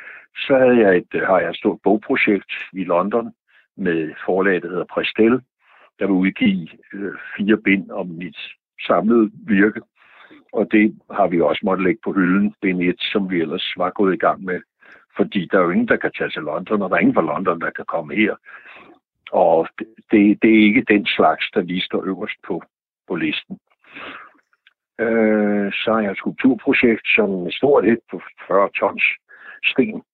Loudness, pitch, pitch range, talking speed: -18 LUFS, 105 Hz, 95-110 Hz, 185 wpm